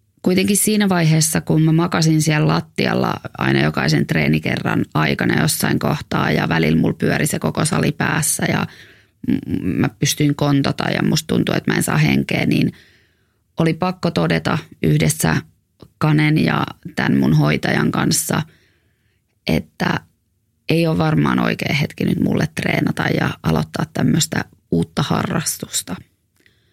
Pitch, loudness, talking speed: 150 Hz, -18 LUFS, 135 wpm